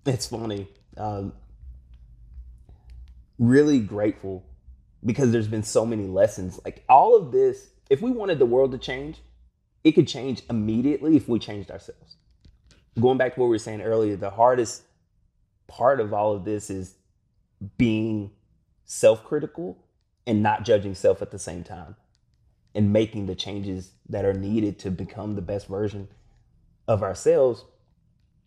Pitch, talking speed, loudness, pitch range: 105 Hz, 150 wpm, -23 LUFS, 95-120 Hz